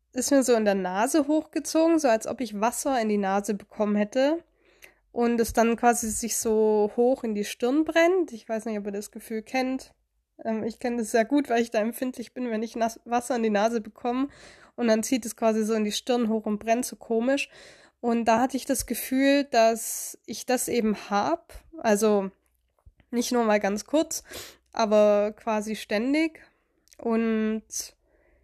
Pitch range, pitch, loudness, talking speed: 220-260 Hz, 230 Hz, -26 LUFS, 185 wpm